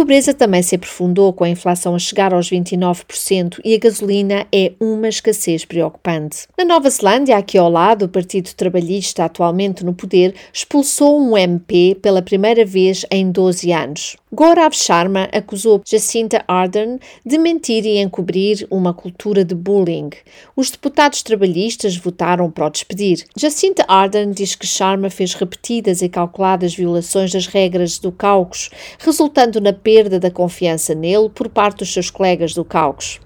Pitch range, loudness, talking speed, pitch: 180-220 Hz, -15 LUFS, 155 wpm, 195 Hz